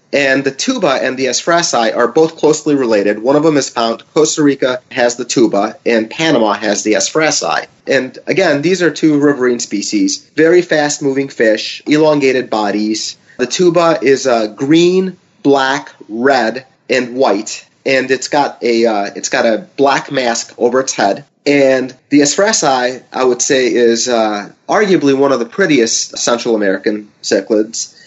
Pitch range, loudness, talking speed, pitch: 115-150 Hz, -13 LUFS, 160 wpm, 130 Hz